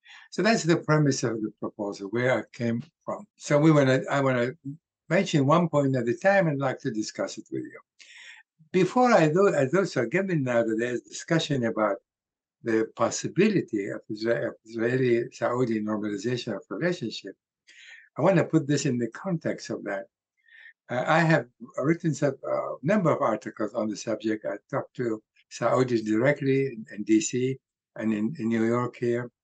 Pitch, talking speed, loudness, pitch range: 130 Hz, 175 wpm, -26 LUFS, 115-160 Hz